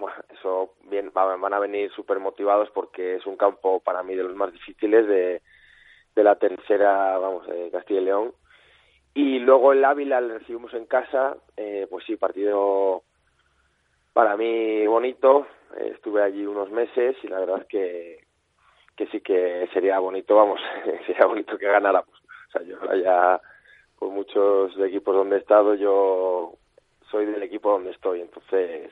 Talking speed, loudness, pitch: 165 wpm, -23 LUFS, 110 Hz